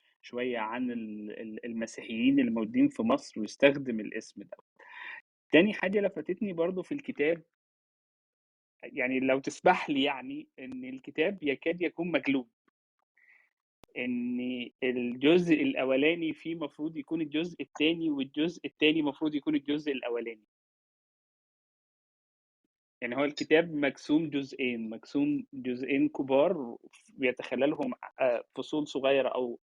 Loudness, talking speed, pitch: -30 LUFS, 105 wpm, 155 Hz